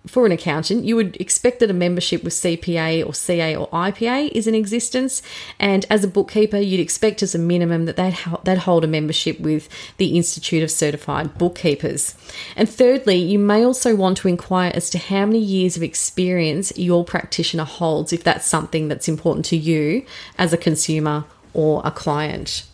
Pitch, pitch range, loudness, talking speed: 175 Hz, 160-200 Hz, -19 LUFS, 180 wpm